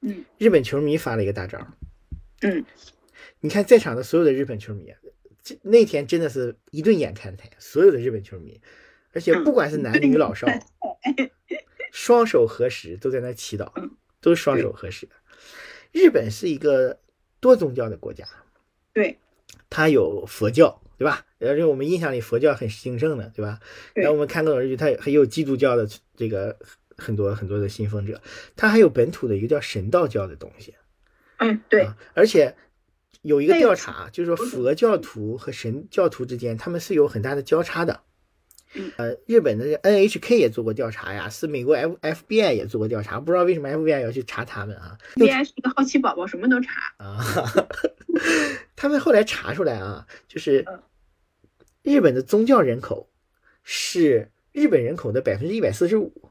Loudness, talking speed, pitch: -21 LUFS, 275 characters per minute, 155 Hz